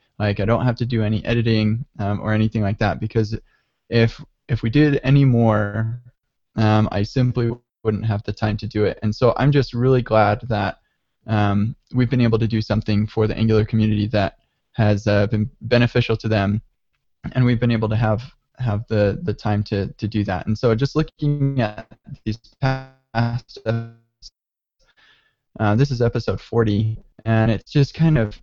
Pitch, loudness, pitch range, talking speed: 110 Hz, -20 LUFS, 105-120 Hz, 185 wpm